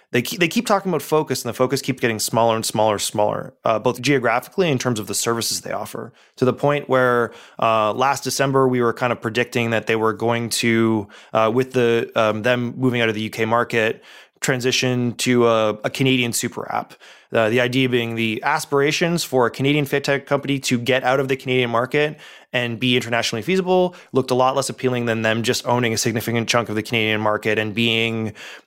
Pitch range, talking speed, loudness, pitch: 115-130 Hz, 215 wpm, -20 LUFS, 120 Hz